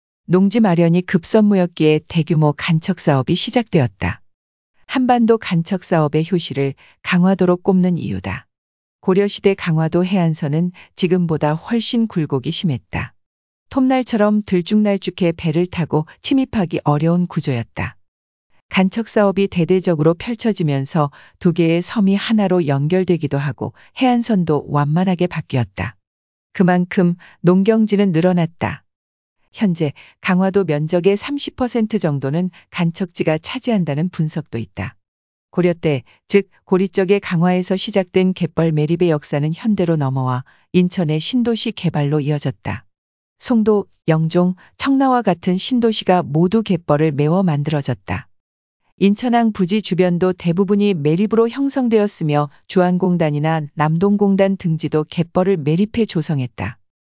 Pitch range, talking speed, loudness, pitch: 150-200 Hz, 295 characters per minute, -18 LUFS, 175 Hz